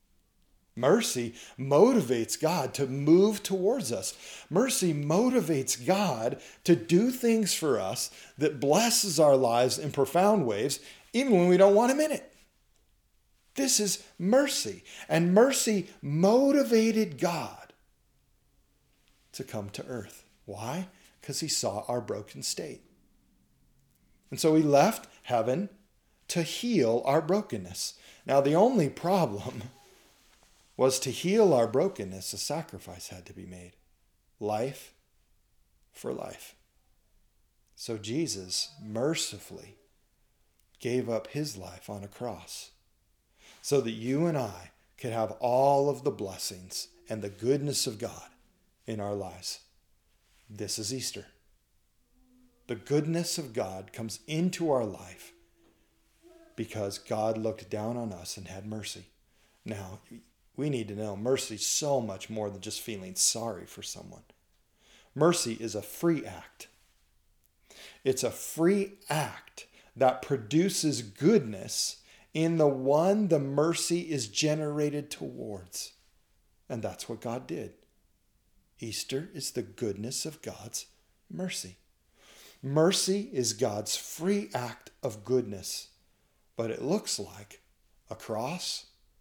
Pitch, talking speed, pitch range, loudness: 135 Hz, 125 wpm, 105-175 Hz, -29 LUFS